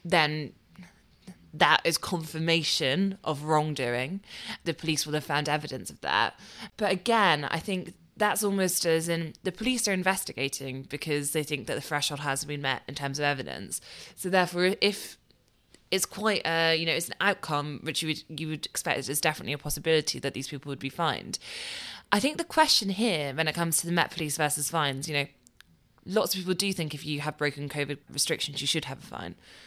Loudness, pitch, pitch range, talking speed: -28 LUFS, 155 Hz, 145-180 Hz, 200 wpm